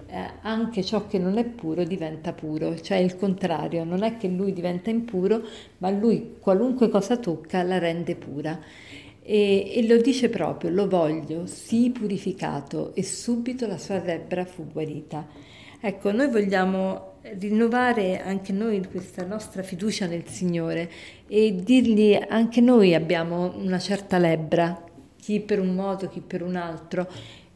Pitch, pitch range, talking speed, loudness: 190 Hz, 170-210 Hz, 150 wpm, -25 LUFS